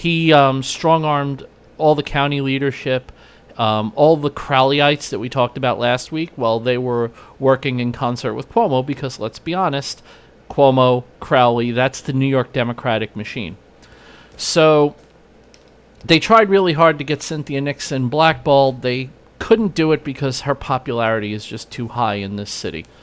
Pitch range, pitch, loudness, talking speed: 120-150 Hz, 135 Hz, -17 LUFS, 165 wpm